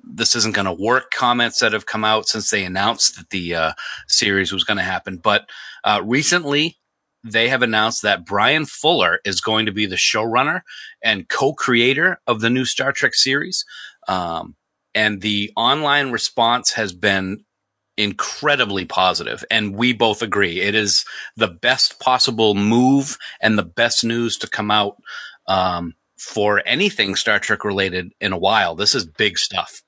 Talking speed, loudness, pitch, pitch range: 170 wpm, -18 LUFS, 110 Hz, 100-120 Hz